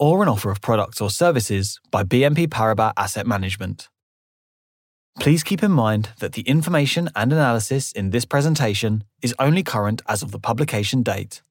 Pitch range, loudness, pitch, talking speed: 105-145 Hz, -20 LUFS, 120 Hz, 165 wpm